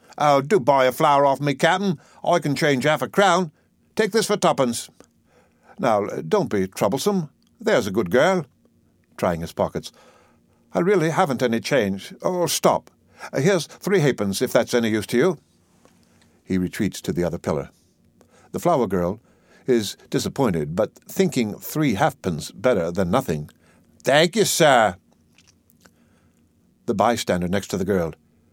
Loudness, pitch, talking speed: -21 LUFS, 120 Hz, 150 wpm